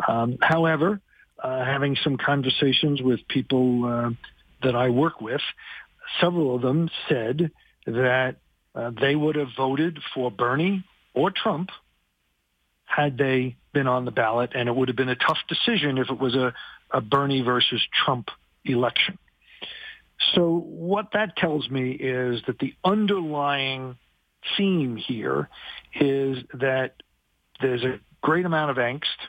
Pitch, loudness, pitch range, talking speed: 135 Hz, -24 LUFS, 125-155 Hz, 140 wpm